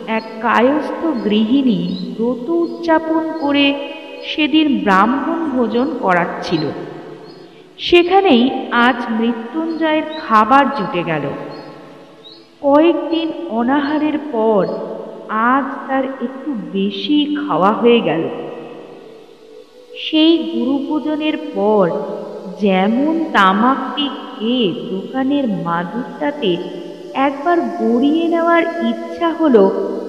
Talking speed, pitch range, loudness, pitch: 80 wpm, 220-310 Hz, -16 LUFS, 265 Hz